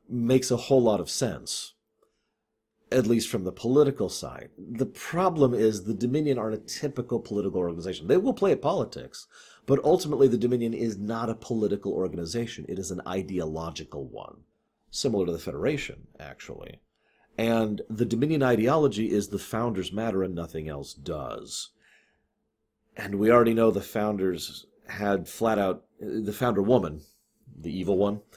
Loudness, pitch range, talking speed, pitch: -27 LUFS, 95-120 Hz, 155 wpm, 110 Hz